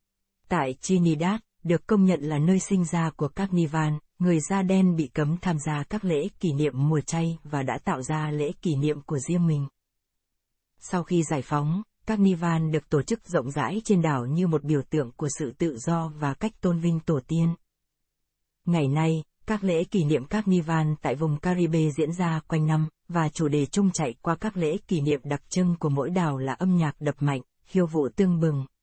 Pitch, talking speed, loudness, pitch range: 165 Hz, 210 wpm, -26 LUFS, 150-180 Hz